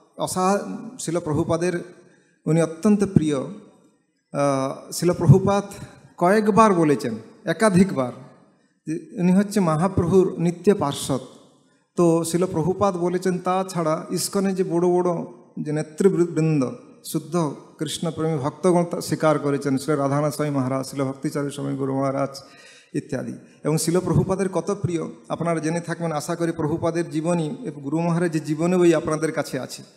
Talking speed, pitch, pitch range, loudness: 115 wpm, 165 Hz, 150-180 Hz, -22 LUFS